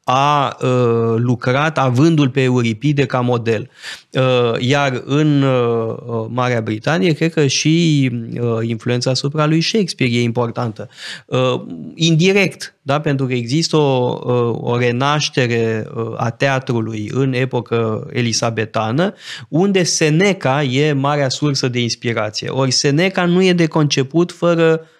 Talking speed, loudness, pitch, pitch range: 125 wpm, -16 LUFS, 130 Hz, 120-150 Hz